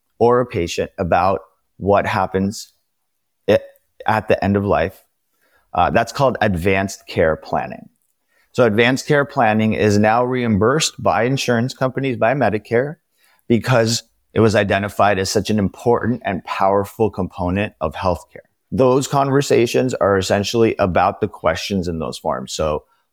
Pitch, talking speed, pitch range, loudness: 110 Hz, 140 wpm, 100-120 Hz, -18 LUFS